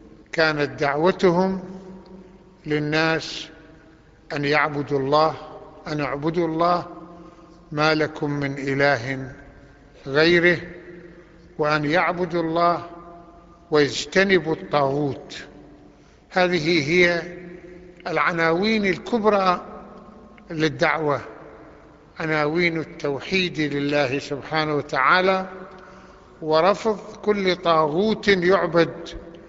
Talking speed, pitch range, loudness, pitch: 65 wpm, 150-180 Hz, -21 LUFS, 170 Hz